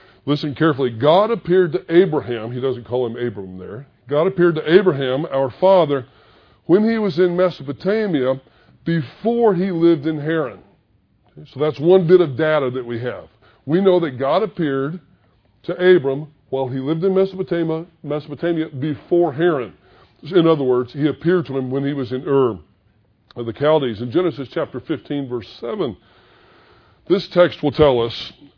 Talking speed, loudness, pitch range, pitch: 160 wpm, -18 LUFS, 125-175 Hz, 145 Hz